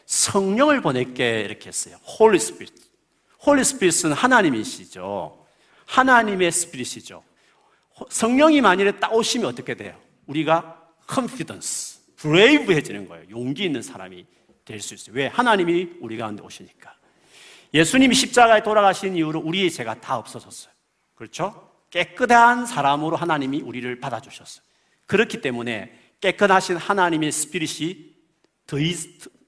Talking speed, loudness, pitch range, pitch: 385 characters per minute, -20 LUFS, 130-215 Hz, 170 Hz